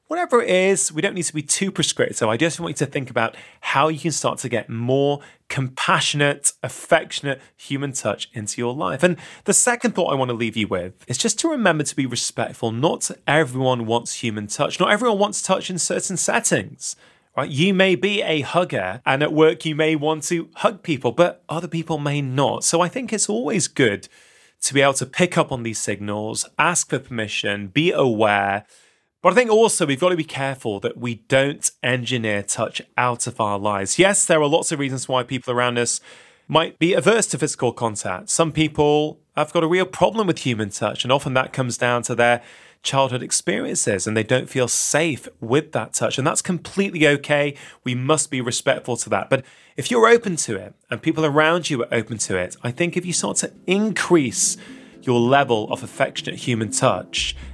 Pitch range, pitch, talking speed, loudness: 120-175 Hz, 145 Hz, 205 wpm, -20 LUFS